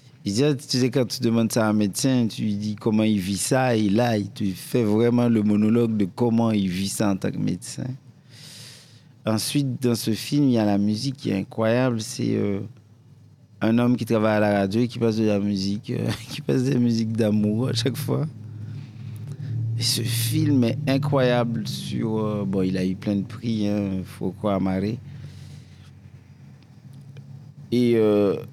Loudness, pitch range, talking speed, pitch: -23 LUFS, 105-130 Hz, 195 wpm, 115 Hz